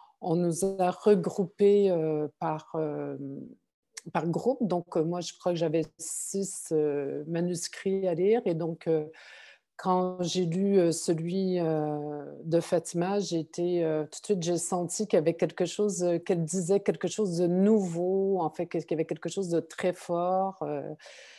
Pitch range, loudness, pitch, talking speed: 165-190 Hz, -29 LUFS, 175 Hz, 170 wpm